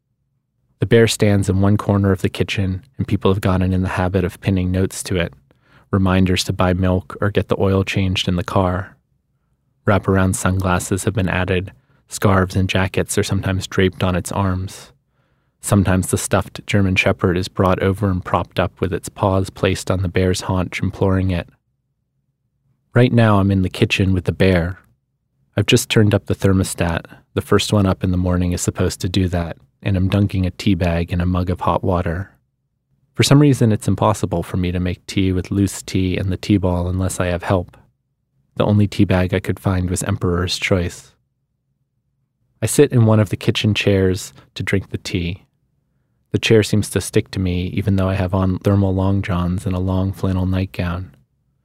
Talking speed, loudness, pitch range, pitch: 200 wpm, -18 LUFS, 95-110 Hz, 100 Hz